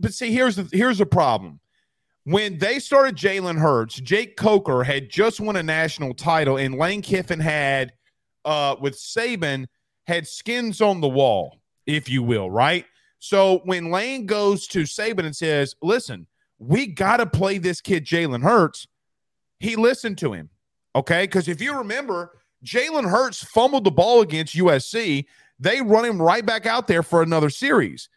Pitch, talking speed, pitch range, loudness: 180 Hz, 170 wpm, 150-220 Hz, -21 LUFS